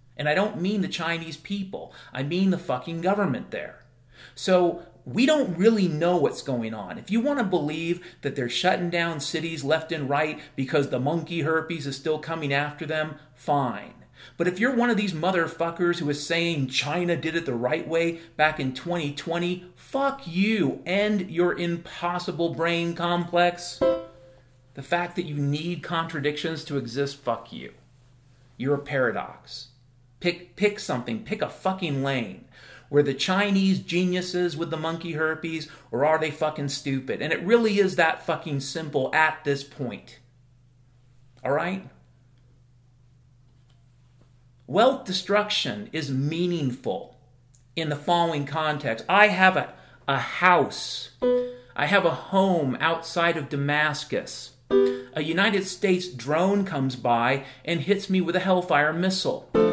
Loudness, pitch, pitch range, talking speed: -25 LUFS, 160 Hz, 135-175 Hz, 150 wpm